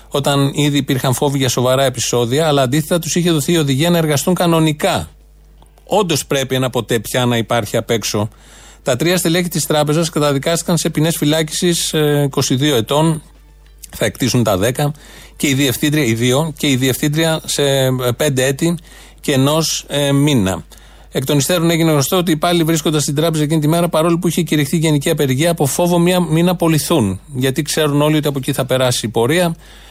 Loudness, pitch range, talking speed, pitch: -15 LUFS, 135-165 Hz, 185 wpm, 150 Hz